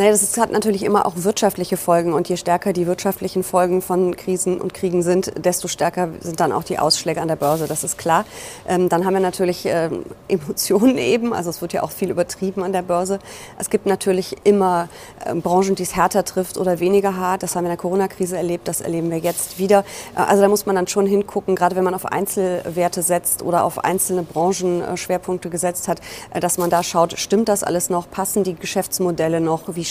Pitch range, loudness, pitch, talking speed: 175-190 Hz, -19 LUFS, 180 Hz, 205 wpm